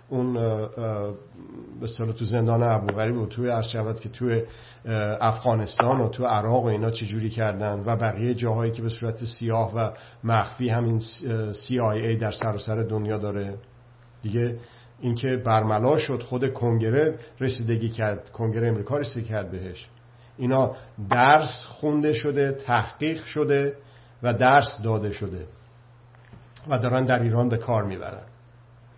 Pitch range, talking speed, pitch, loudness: 110-125 Hz, 140 wpm, 115 Hz, -25 LUFS